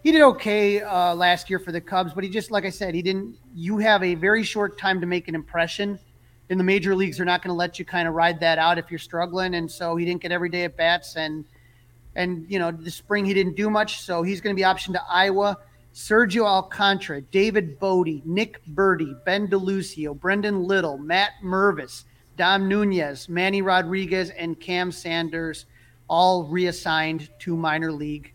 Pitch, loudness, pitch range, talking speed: 180 Hz, -23 LUFS, 165-195 Hz, 205 wpm